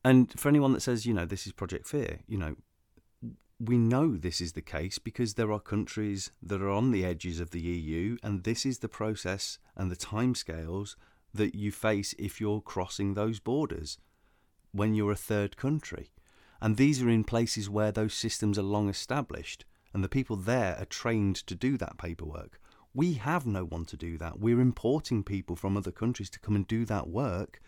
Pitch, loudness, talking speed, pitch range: 105 Hz, -31 LUFS, 200 wpm, 95-115 Hz